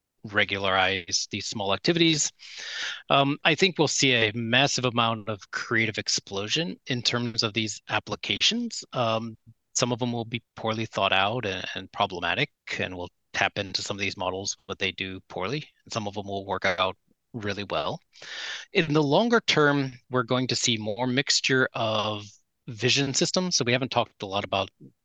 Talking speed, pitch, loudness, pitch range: 175 wpm, 115 Hz, -26 LUFS, 100-130 Hz